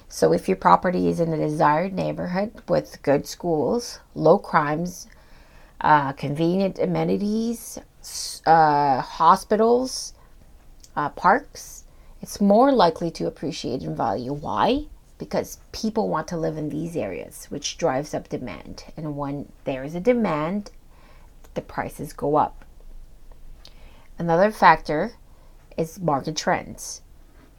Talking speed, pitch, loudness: 120 wpm, 160 Hz, -23 LUFS